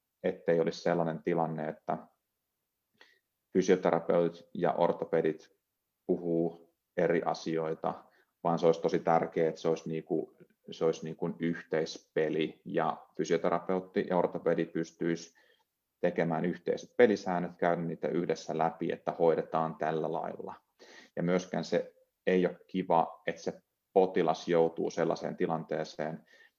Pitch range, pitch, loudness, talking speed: 80-85 Hz, 85 Hz, -32 LUFS, 120 wpm